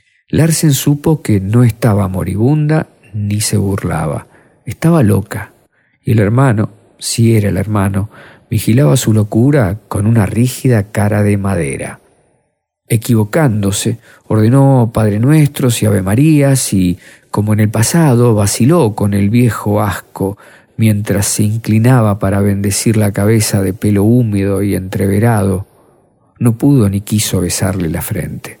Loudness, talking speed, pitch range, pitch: -12 LUFS, 130 wpm, 100-125 Hz, 110 Hz